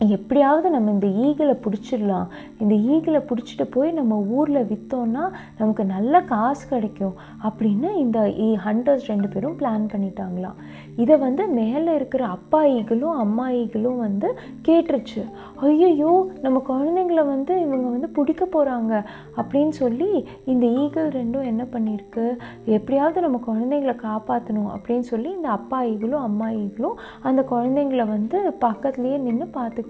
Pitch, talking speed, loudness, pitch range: 245 Hz, 120 wpm, -22 LUFS, 220-285 Hz